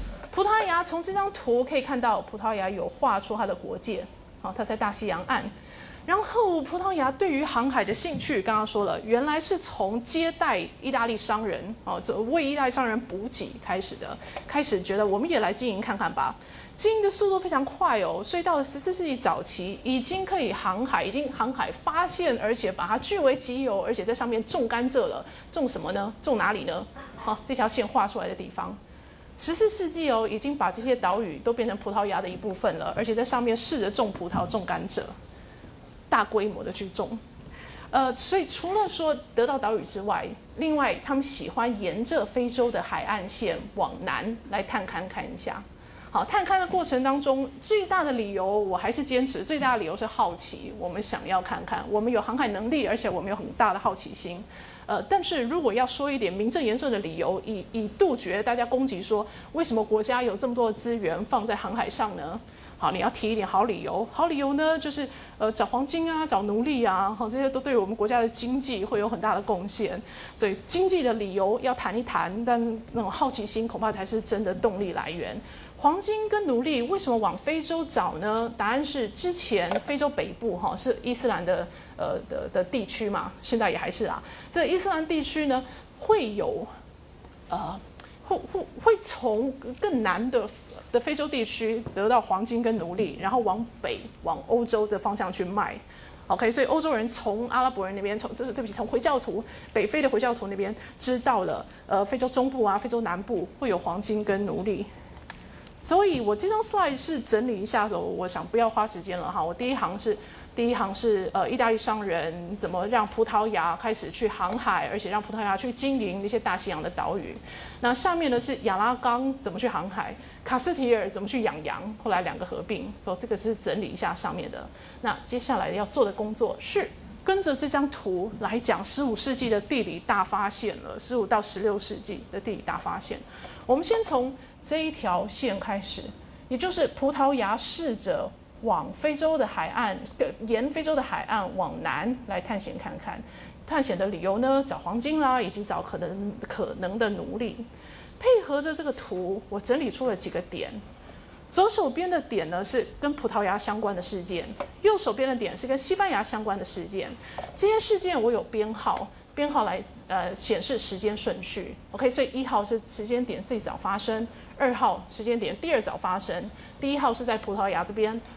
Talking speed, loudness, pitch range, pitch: 295 characters per minute, -28 LUFS, 215-285 Hz, 240 Hz